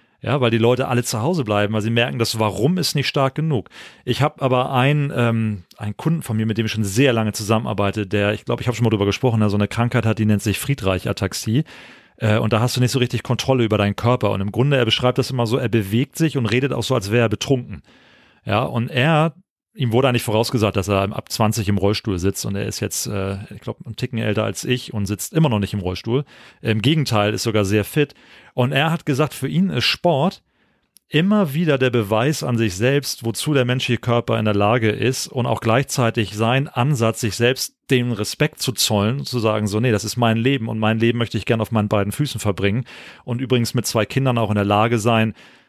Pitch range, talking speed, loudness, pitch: 110-130 Hz, 245 wpm, -20 LUFS, 120 Hz